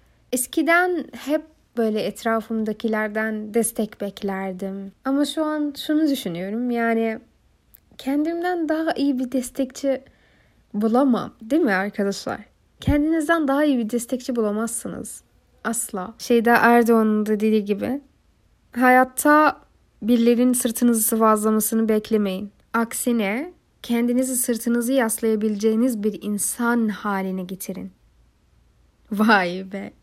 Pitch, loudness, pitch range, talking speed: 235 Hz, -21 LUFS, 215-260 Hz, 95 wpm